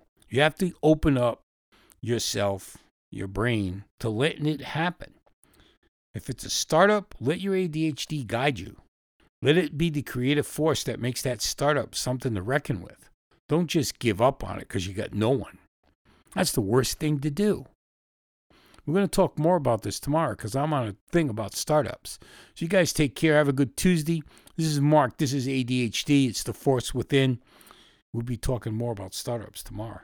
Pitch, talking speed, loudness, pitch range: 135 Hz, 185 wpm, -26 LUFS, 115-155 Hz